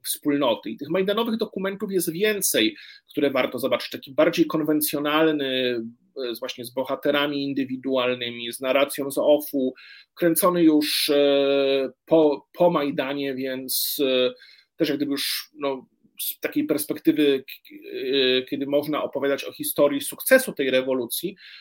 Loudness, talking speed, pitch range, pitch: -23 LUFS, 120 wpm, 135-165 Hz, 145 Hz